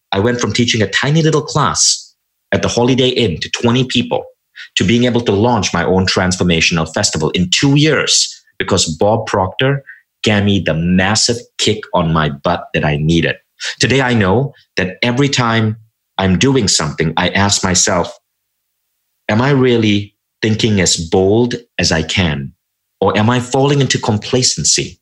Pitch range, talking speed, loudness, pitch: 95-130 Hz, 165 wpm, -14 LUFS, 110 Hz